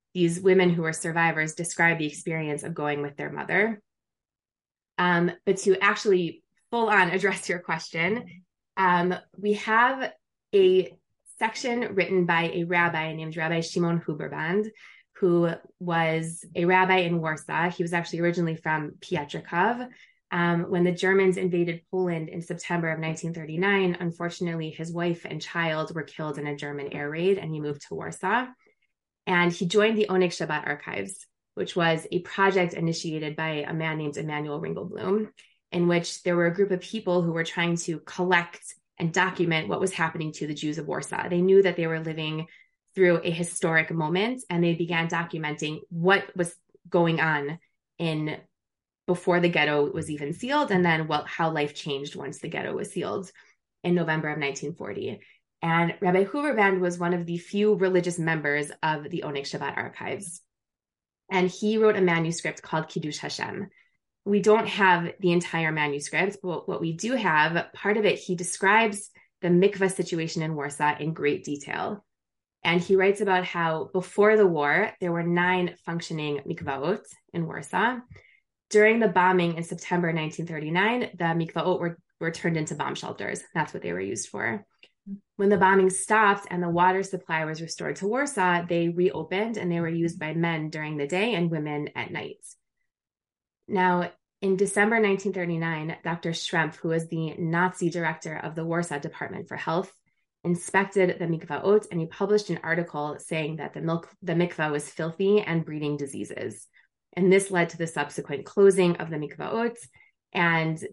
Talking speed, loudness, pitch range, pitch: 170 wpm, -26 LUFS, 160-190 Hz, 175 Hz